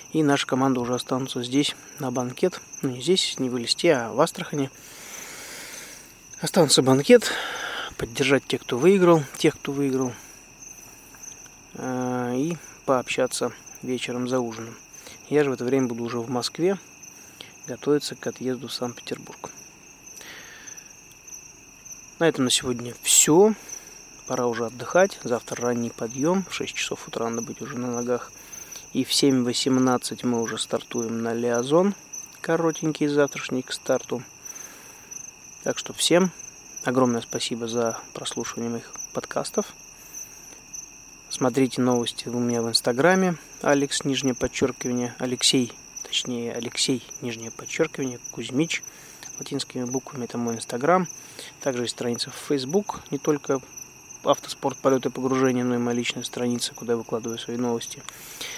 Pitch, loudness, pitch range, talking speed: 130 Hz, -24 LUFS, 120-145 Hz, 130 wpm